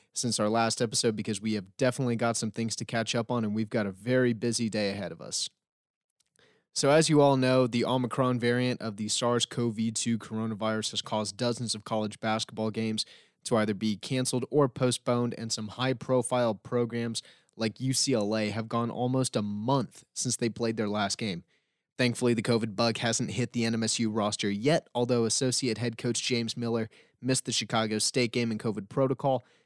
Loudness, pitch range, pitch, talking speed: -29 LUFS, 110-125 Hz, 115 Hz, 190 wpm